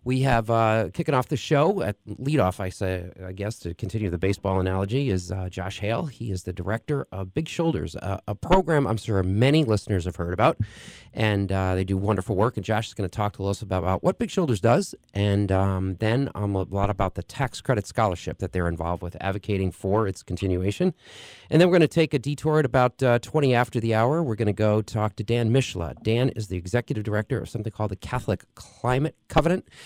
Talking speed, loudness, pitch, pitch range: 225 wpm, -25 LUFS, 110 Hz, 95-125 Hz